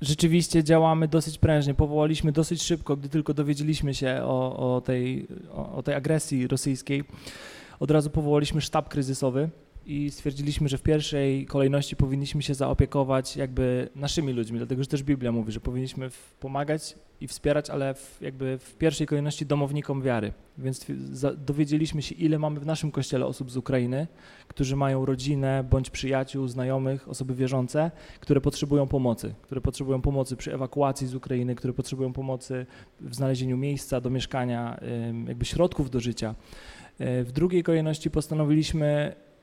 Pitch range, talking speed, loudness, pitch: 130-150 Hz, 150 wpm, -27 LUFS, 140 Hz